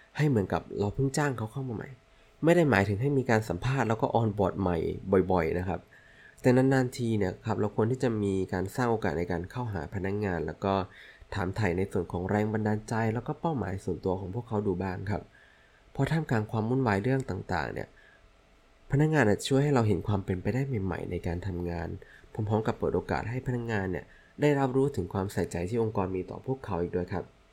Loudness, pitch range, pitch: -30 LUFS, 95-125 Hz, 105 Hz